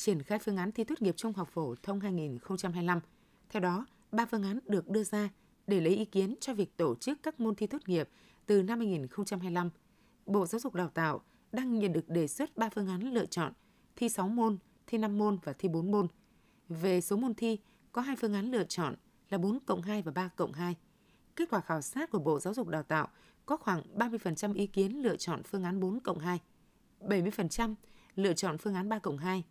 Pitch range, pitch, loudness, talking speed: 180-225 Hz, 200 Hz, -34 LUFS, 220 wpm